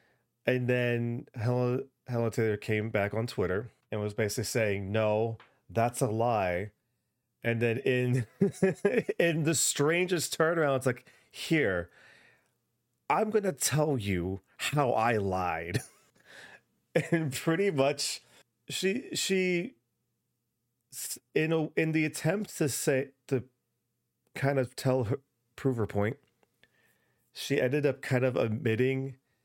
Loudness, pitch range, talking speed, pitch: -30 LUFS, 115-145 Hz, 120 wpm, 125 Hz